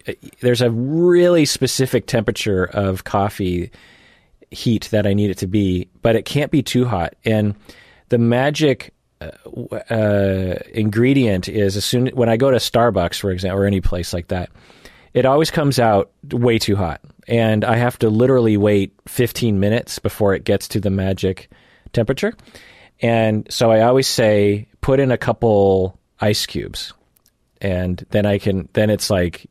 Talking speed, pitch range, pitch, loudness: 165 wpm, 100-120 Hz, 110 Hz, -18 LUFS